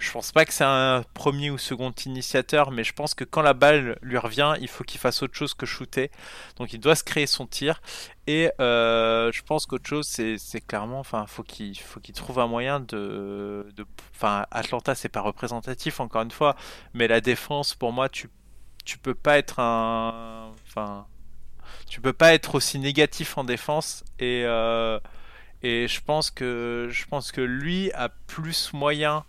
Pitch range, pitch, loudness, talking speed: 115-145 Hz, 130 Hz, -25 LUFS, 190 wpm